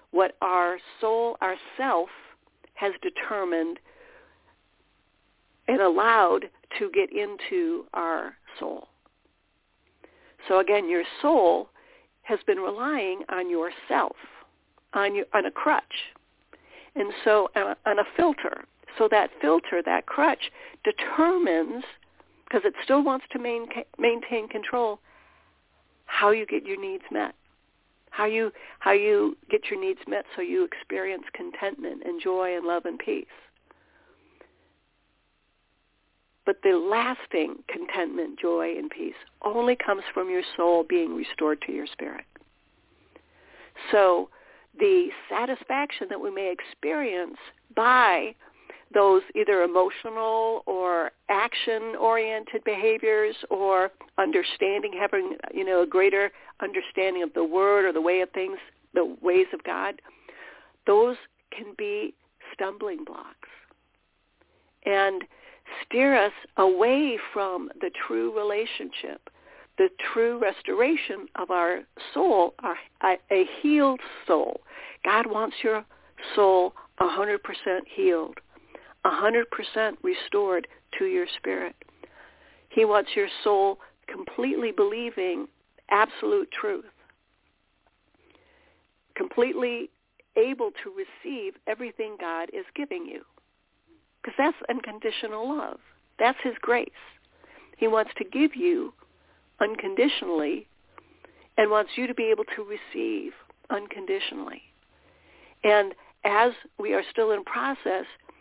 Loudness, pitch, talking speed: -26 LUFS, 265 Hz, 115 wpm